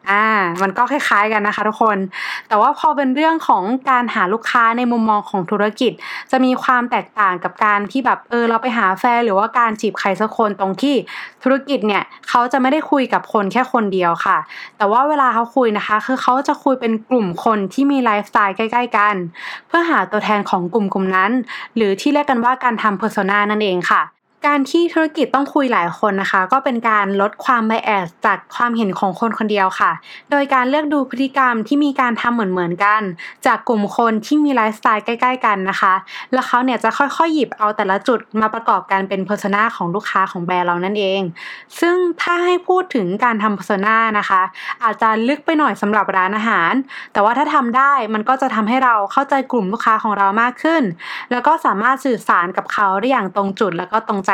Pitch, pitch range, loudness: 225 Hz, 205-265 Hz, -16 LUFS